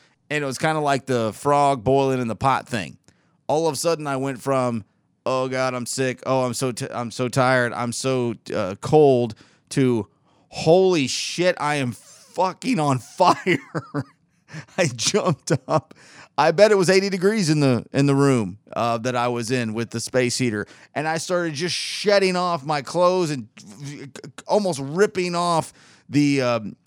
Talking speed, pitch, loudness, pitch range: 180 wpm, 140 Hz, -21 LUFS, 125-165 Hz